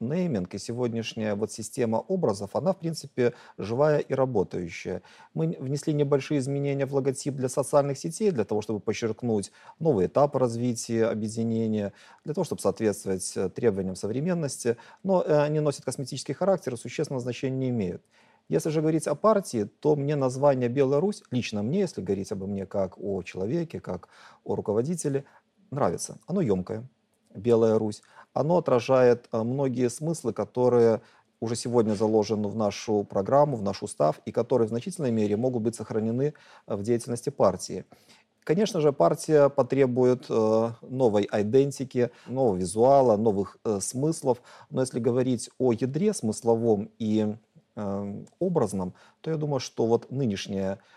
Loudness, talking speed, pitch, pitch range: -27 LUFS, 140 wpm, 125 Hz, 110-145 Hz